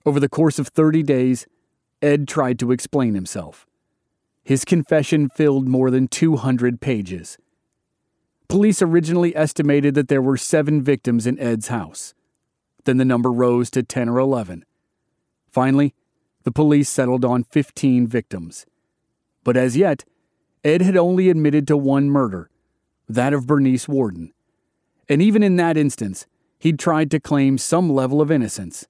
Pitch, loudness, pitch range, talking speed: 140 Hz, -18 LUFS, 125-155 Hz, 145 wpm